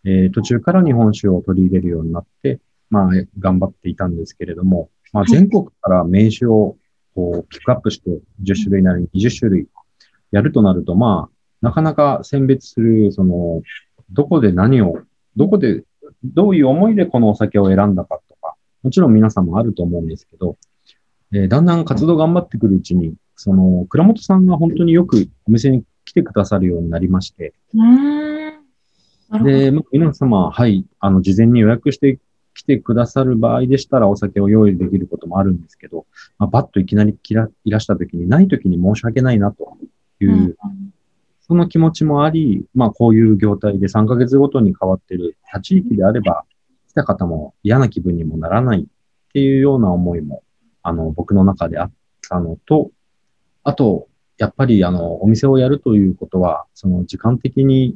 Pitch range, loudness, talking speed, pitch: 95-135 Hz, -15 LUFS, 345 characters per minute, 110 Hz